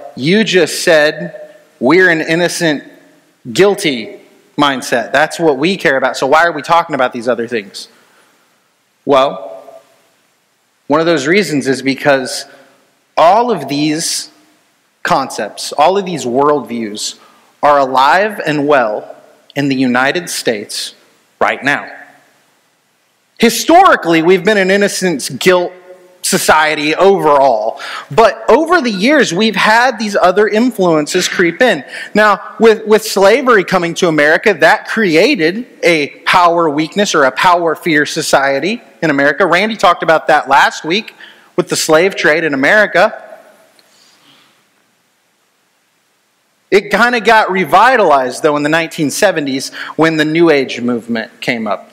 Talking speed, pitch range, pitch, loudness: 130 wpm, 150-205 Hz, 170 Hz, -11 LUFS